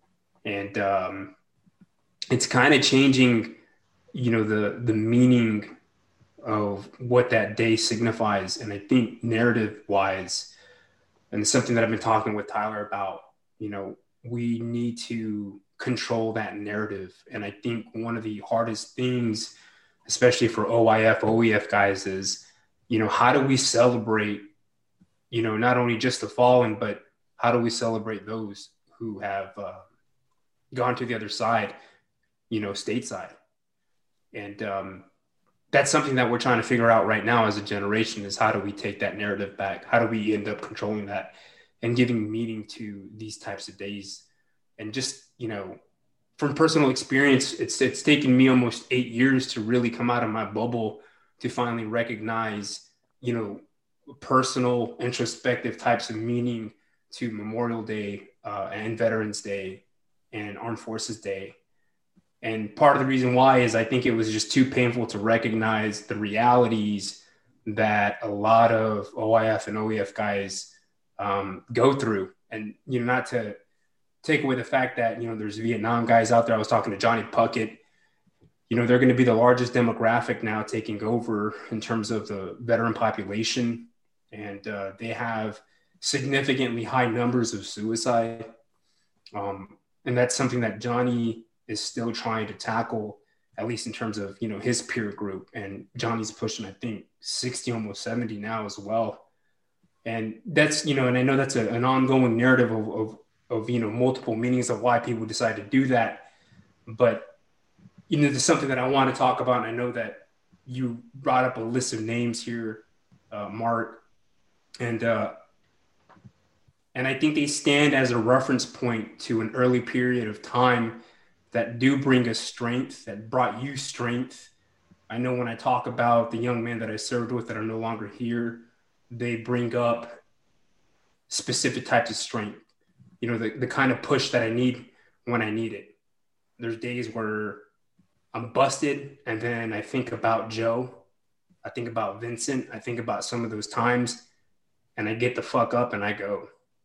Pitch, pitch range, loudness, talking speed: 115 Hz, 110-125 Hz, -25 LUFS, 170 wpm